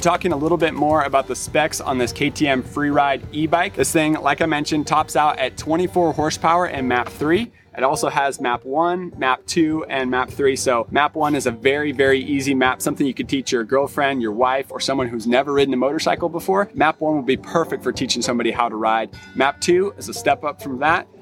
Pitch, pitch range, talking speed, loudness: 140 Hz, 130-160 Hz, 225 wpm, -19 LUFS